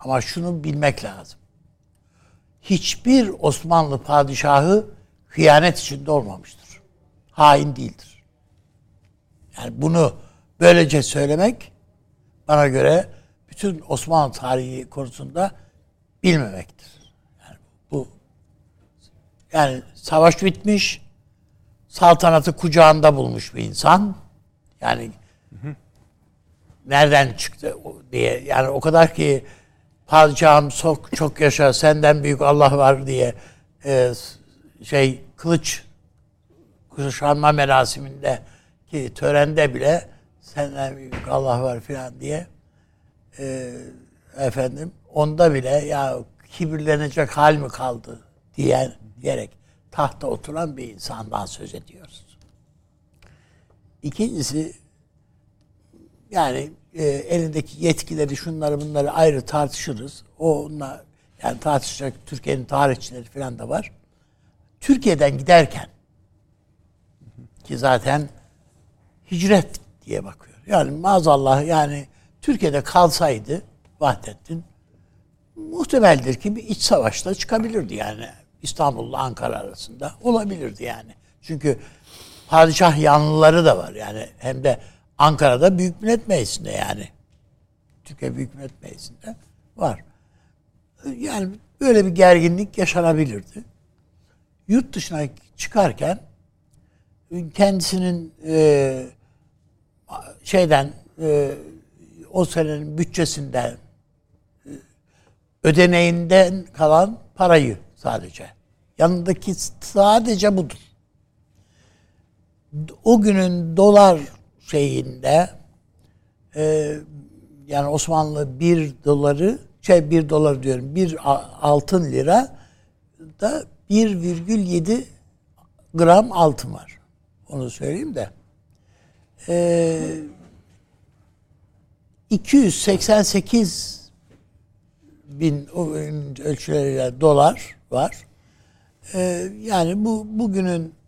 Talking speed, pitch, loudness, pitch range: 85 wpm, 145 Hz, -19 LUFS, 125-170 Hz